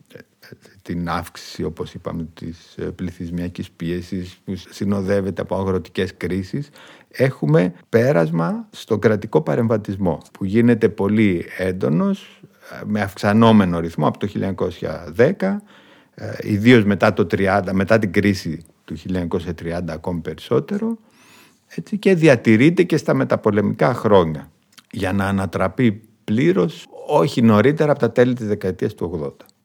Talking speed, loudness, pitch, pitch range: 115 wpm, -19 LUFS, 100 Hz, 90-115 Hz